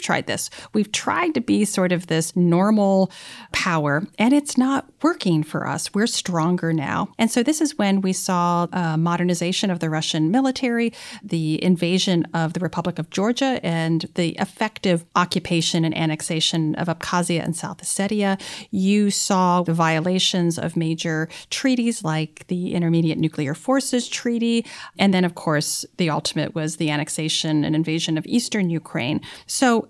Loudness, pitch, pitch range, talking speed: -21 LUFS, 180 Hz, 165-205 Hz, 155 wpm